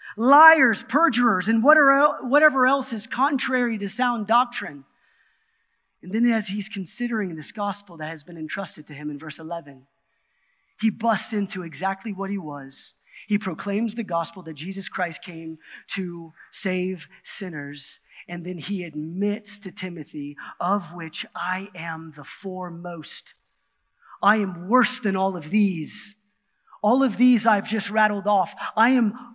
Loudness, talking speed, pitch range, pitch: -23 LUFS, 145 wpm, 170-230 Hz, 200 Hz